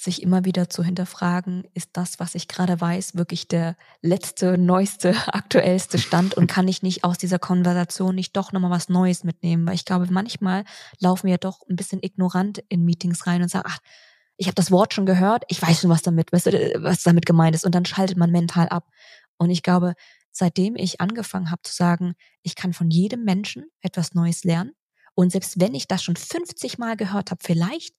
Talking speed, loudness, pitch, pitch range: 205 wpm, -22 LUFS, 180 Hz, 175-190 Hz